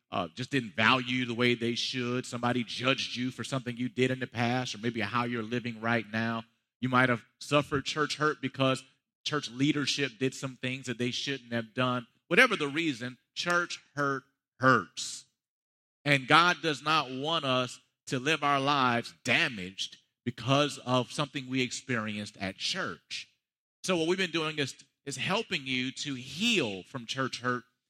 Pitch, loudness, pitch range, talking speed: 130 Hz, -30 LUFS, 120-140 Hz, 170 wpm